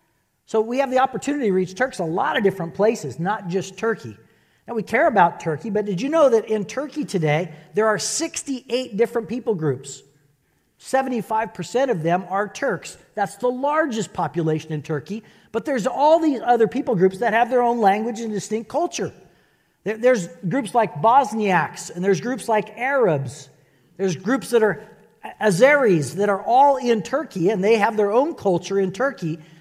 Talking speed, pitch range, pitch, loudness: 180 wpm, 180-245 Hz, 215 Hz, -21 LUFS